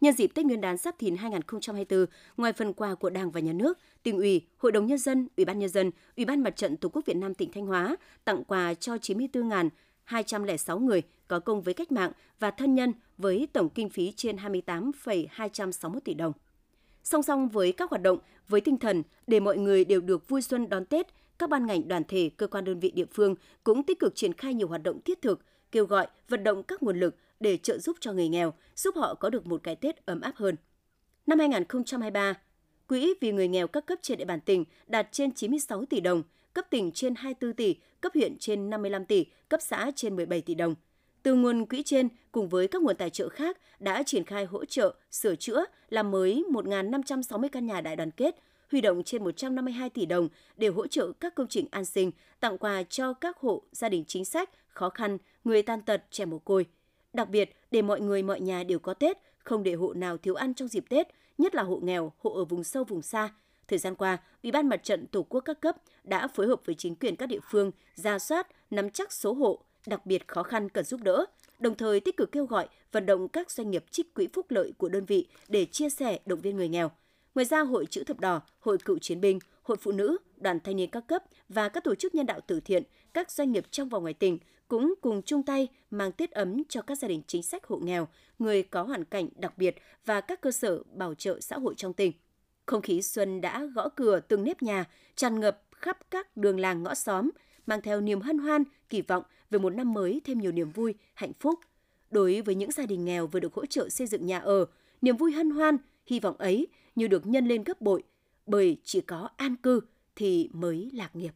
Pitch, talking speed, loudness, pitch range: 220 Hz, 235 wpm, -30 LUFS, 190-290 Hz